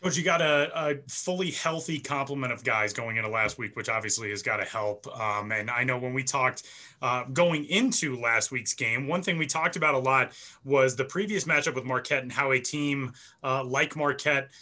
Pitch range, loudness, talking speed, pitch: 125-150 Hz, -27 LUFS, 220 wpm, 135 Hz